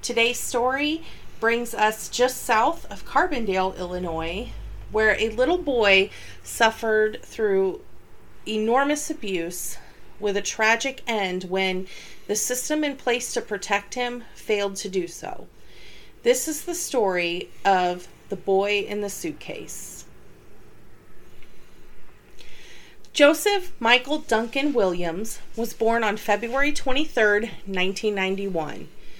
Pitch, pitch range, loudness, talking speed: 220 Hz, 195-255 Hz, -23 LUFS, 110 wpm